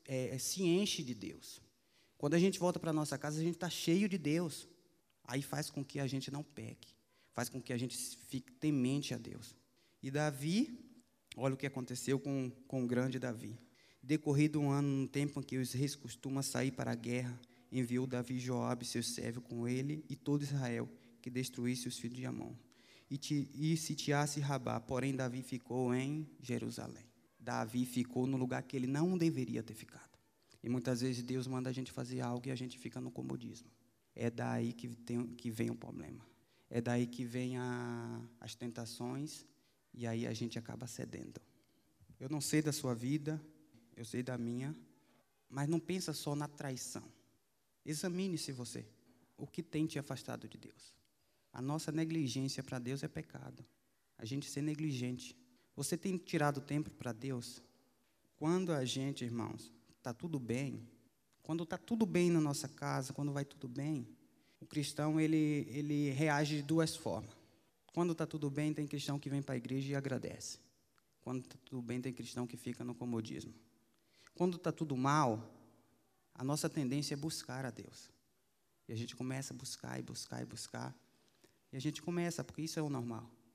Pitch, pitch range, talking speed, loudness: 130 Hz, 120-150 Hz, 180 wpm, -39 LUFS